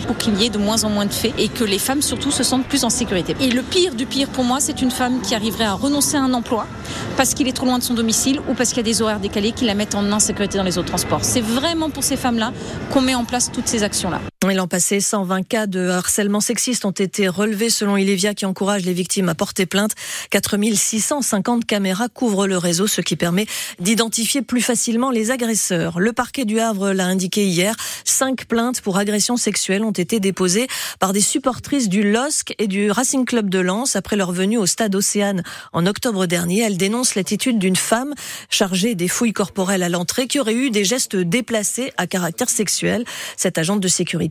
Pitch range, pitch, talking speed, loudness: 195-245 Hz, 215 Hz, 225 wpm, -18 LUFS